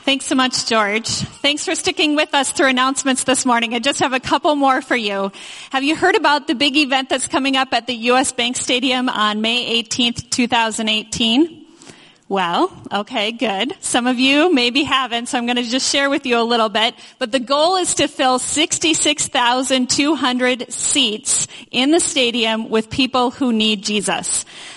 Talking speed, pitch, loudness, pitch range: 180 wpm, 260 Hz, -16 LUFS, 240-295 Hz